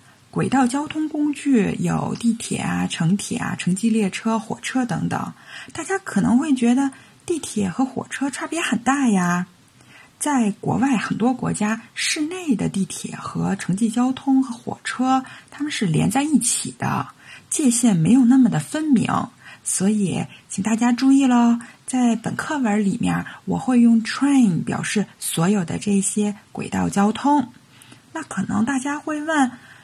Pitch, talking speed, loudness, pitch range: 235 Hz, 230 characters per minute, -21 LUFS, 205-270 Hz